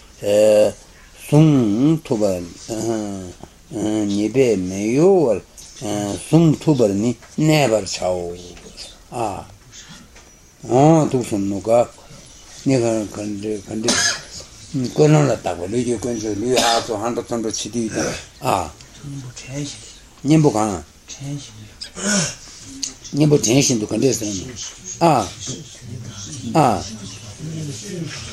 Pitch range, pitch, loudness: 105-135 Hz, 115 Hz, -19 LUFS